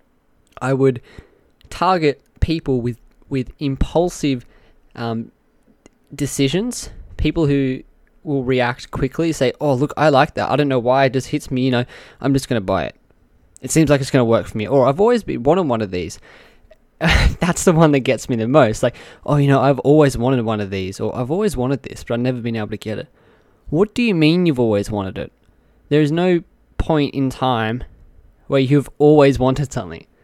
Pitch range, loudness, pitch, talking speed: 120-150 Hz, -18 LUFS, 135 Hz, 205 wpm